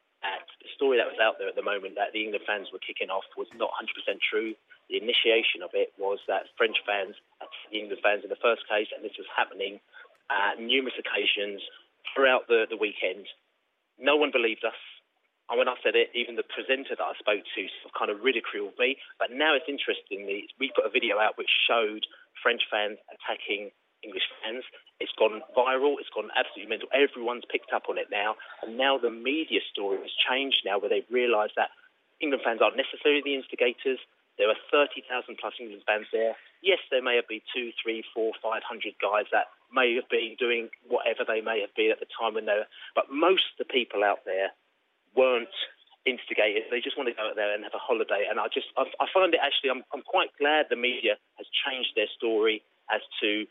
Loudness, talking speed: -28 LUFS, 215 wpm